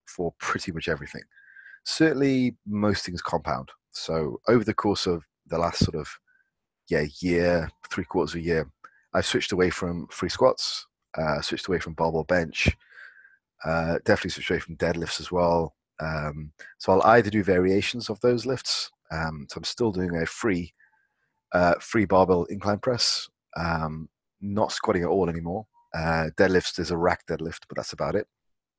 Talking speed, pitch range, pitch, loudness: 170 wpm, 80-105 Hz, 90 Hz, -26 LUFS